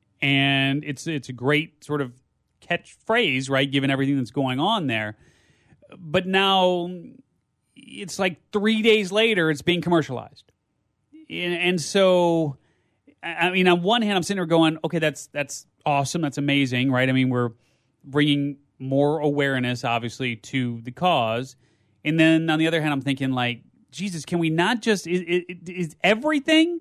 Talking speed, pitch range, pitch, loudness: 155 wpm, 135-180 Hz, 155 Hz, -22 LUFS